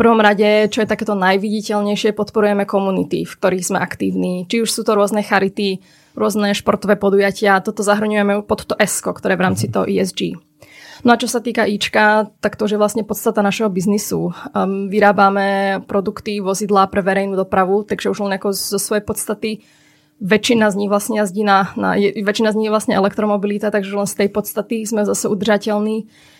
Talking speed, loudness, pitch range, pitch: 185 wpm, -17 LUFS, 195-215 Hz, 205 Hz